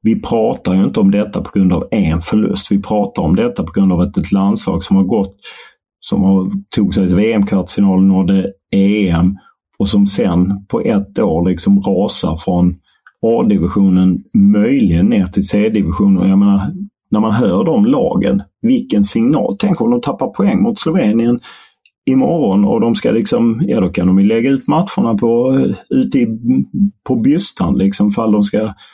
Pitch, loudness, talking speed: 105 Hz, -14 LUFS, 175 wpm